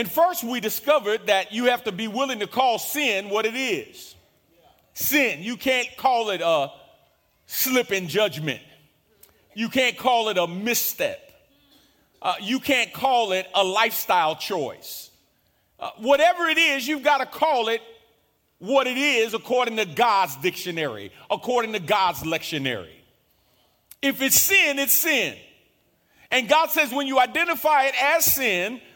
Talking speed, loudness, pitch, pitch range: 150 wpm, -22 LUFS, 245 Hz, 215-285 Hz